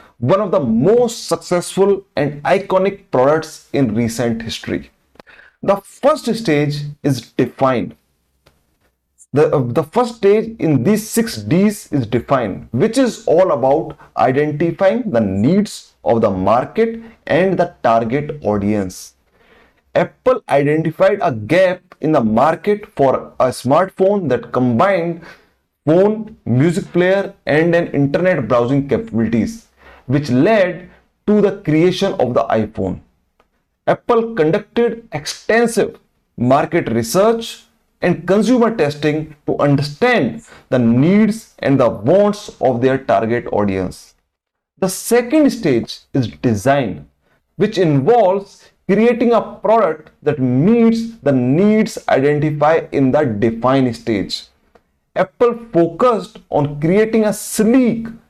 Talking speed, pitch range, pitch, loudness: 115 wpm, 140-215 Hz, 175 Hz, -16 LUFS